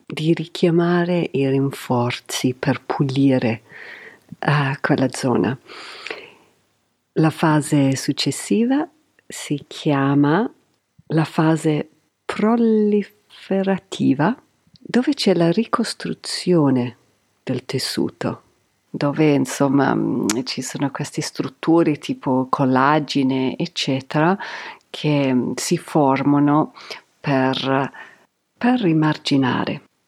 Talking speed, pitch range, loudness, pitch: 80 wpm, 135-175 Hz, -20 LUFS, 150 Hz